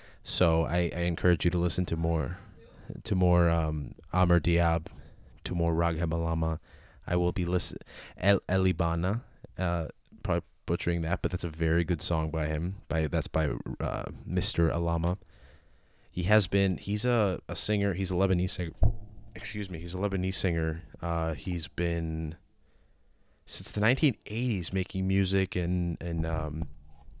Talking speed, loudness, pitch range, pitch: 155 wpm, -29 LUFS, 80-95 Hz, 85 Hz